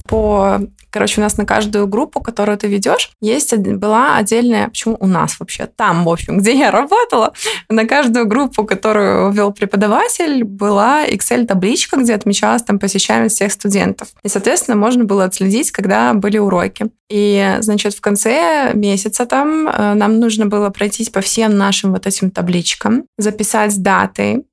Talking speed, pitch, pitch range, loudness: 155 wpm, 210 Hz, 205-230 Hz, -14 LUFS